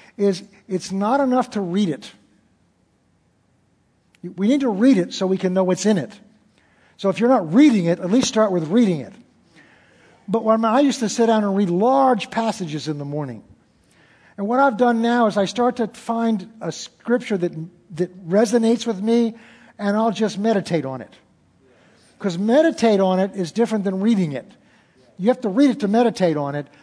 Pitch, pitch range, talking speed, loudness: 205 Hz, 175-230 Hz, 190 wpm, -20 LUFS